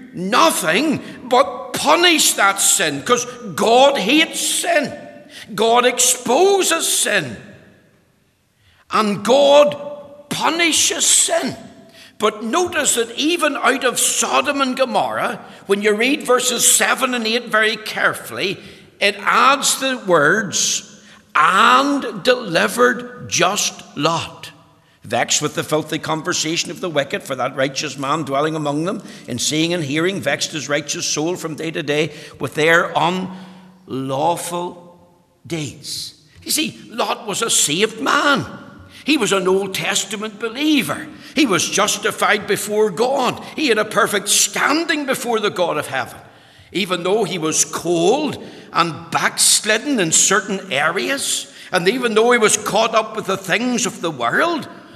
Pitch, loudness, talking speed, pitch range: 205 Hz, -17 LUFS, 135 wpm, 170-250 Hz